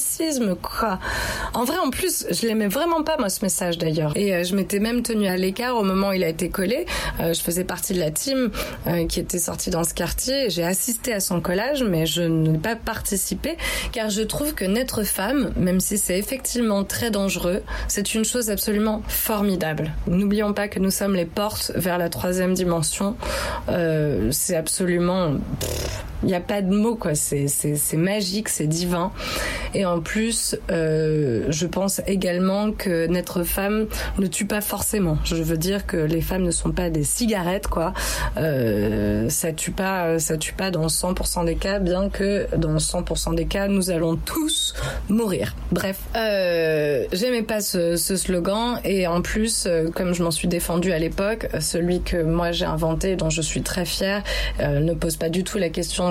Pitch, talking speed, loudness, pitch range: 185 Hz, 190 wpm, -22 LUFS, 165-205 Hz